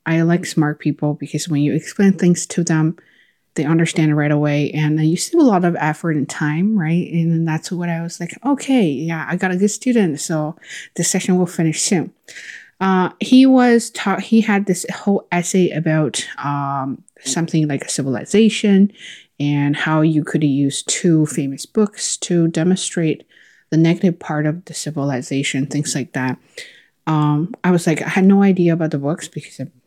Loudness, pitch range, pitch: -17 LUFS, 150-185 Hz, 165 Hz